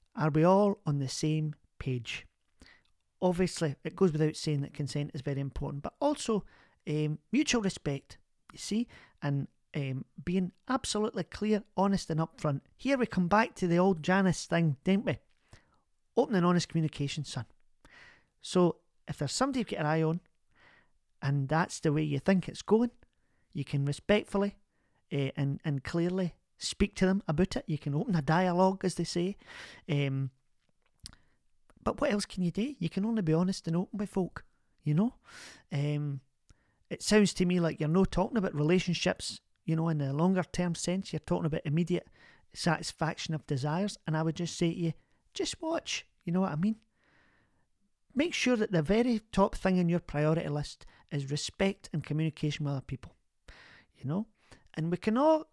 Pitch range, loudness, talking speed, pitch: 150-195 Hz, -31 LUFS, 180 wpm, 170 Hz